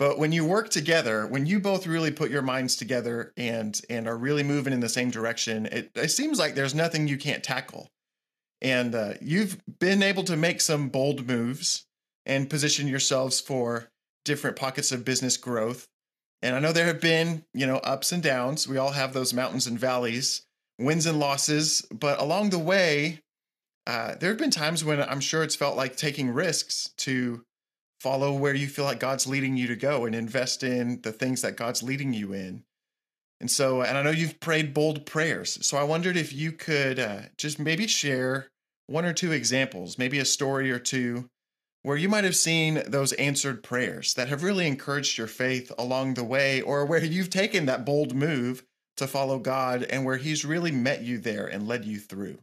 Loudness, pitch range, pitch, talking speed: -26 LUFS, 125-155 Hz, 135 Hz, 200 wpm